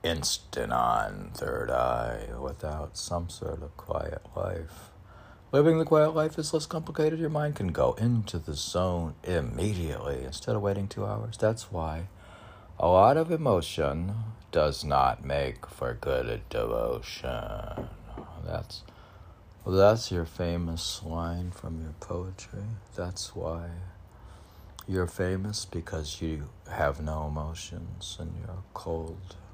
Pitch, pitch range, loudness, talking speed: 95 Hz, 85-110 Hz, -30 LUFS, 130 wpm